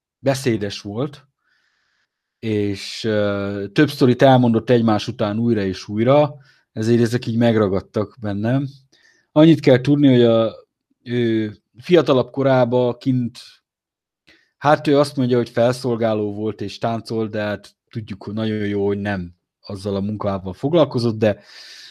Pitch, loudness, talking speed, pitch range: 115 Hz, -19 LUFS, 130 wpm, 105-130 Hz